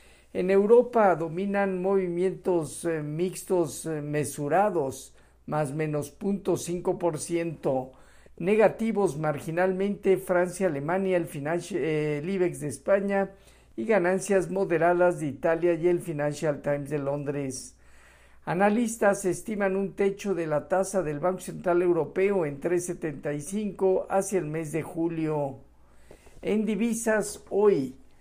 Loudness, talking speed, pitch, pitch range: -27 LUFS, 110 wpm, 175 Hz, 150-195 Hz